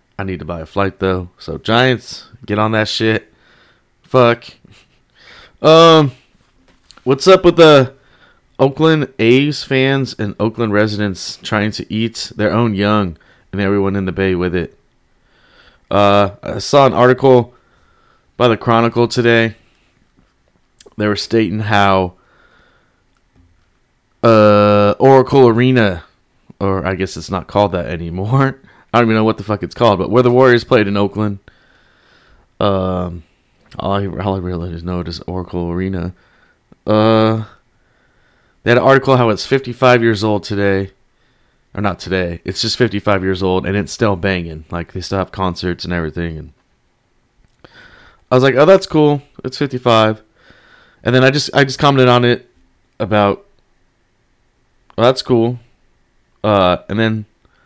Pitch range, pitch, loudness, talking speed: 95-125 Hz, 105 Hz, -14 LUFS, 150 wpm